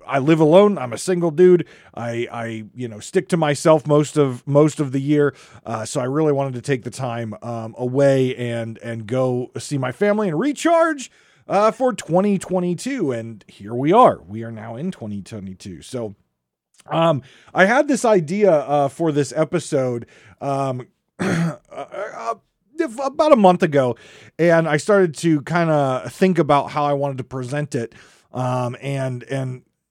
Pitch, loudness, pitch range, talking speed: 145 Hz, -19 LUFS, 125-180 Hz, 165 wpm